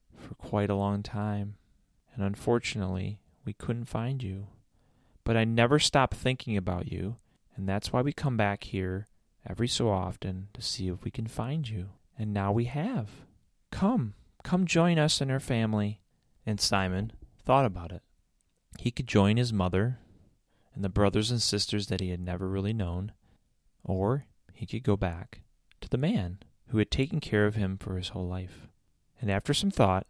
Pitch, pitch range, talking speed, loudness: 105 Hz, 95-120 Hz, 175 wpm, -30 LUFS